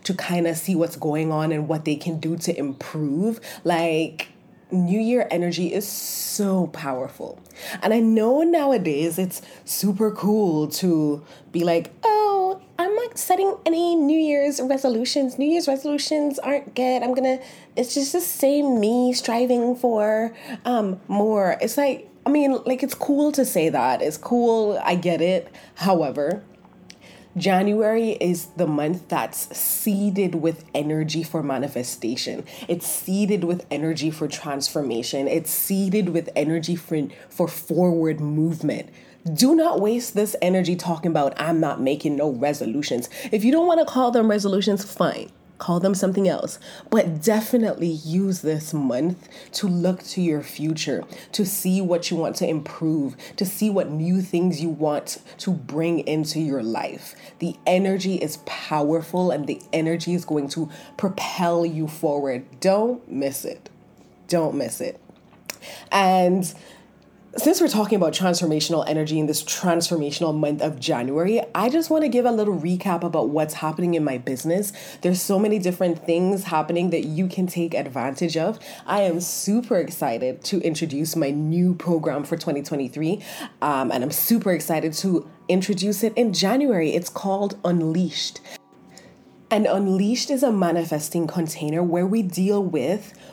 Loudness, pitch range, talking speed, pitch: -22 LUFS, 160-215 Hz, 155 wpm, 180 Hz